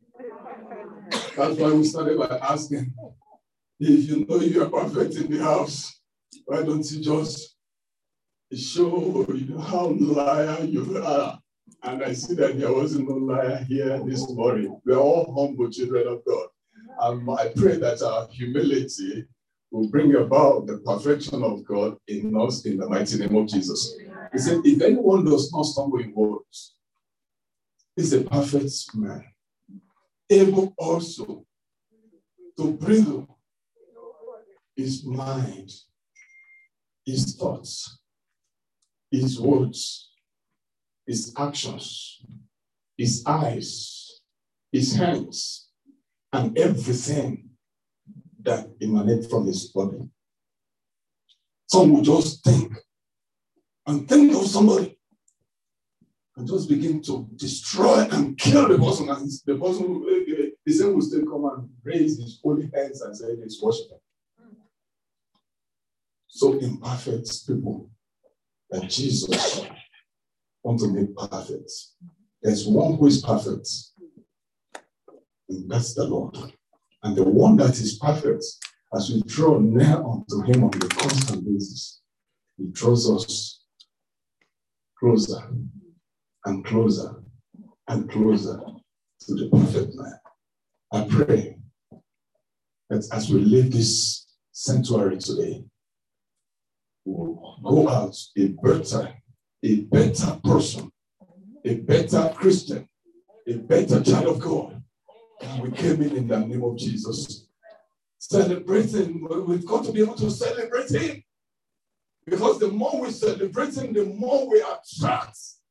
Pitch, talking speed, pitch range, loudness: 140 Hz, 120 wpm, 120-195 Hz, -23 LUFS